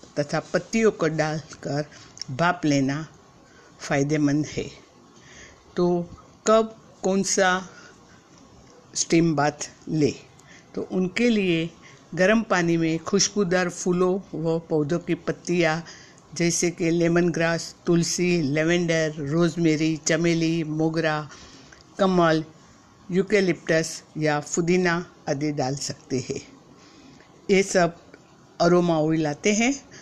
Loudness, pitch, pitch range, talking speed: -23 LUFS, 165 Hz, 155-180 Hz, 100 wpm